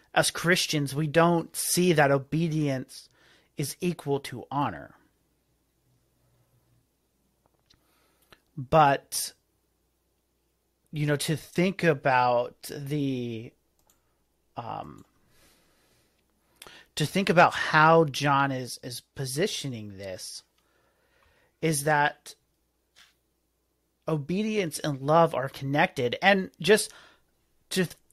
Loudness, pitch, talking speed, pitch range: -26 LUFS, 150 Hz, 85 wpm, 130-165 Hz